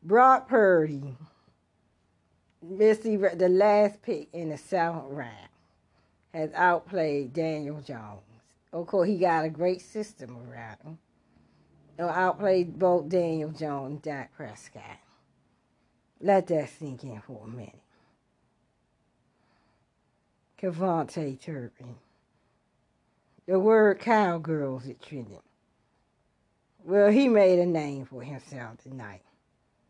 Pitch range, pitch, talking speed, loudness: 120-185 Hz, 155 Hz, 105 wpm, -25 LUFS